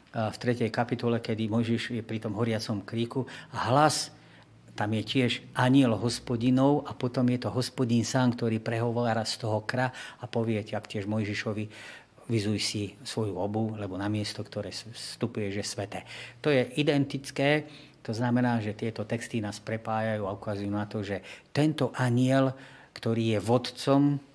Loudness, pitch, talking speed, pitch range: -29 LUFS, 115 Hz, 160 wpm, 110-130 Hz